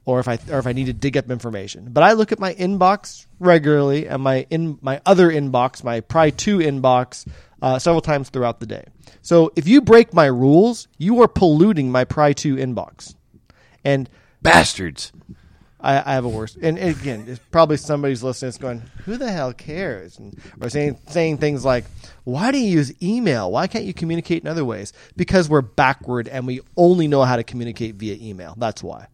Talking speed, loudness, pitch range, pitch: 205 wpm, -18 LUFS, 125-170 Hz, 140 Hz